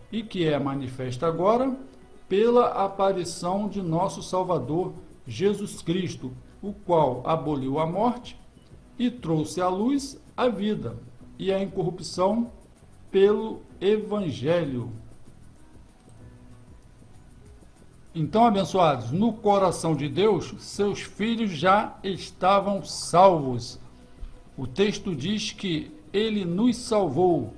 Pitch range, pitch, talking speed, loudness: 160-205 Hz, 185 Hz, 100 wpm, -25 LUFS